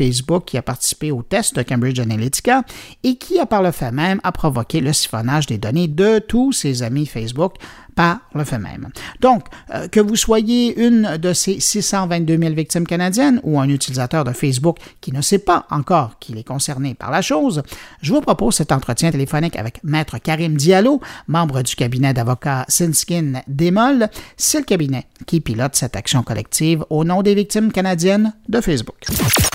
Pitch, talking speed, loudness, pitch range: 160 Hz, 180 wpm, -17 LUFS, 130-200 Hz